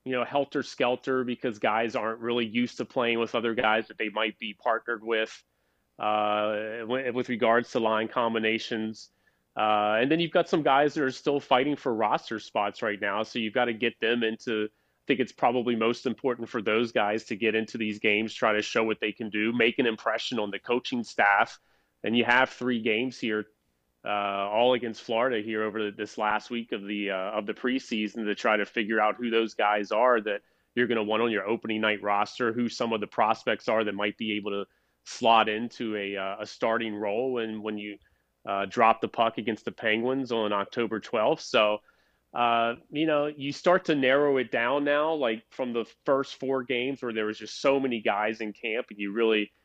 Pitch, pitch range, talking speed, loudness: 115 Hz, 105-125 Hz, 215 wpm, -27 LUFS